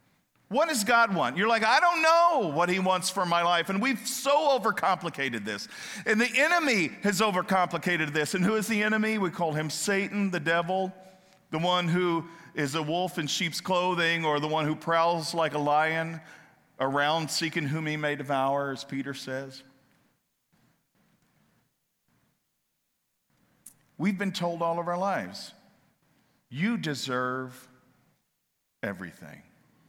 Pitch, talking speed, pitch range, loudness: 170 Hz, 145 wpm, 150-200 Hz, -27 LUFS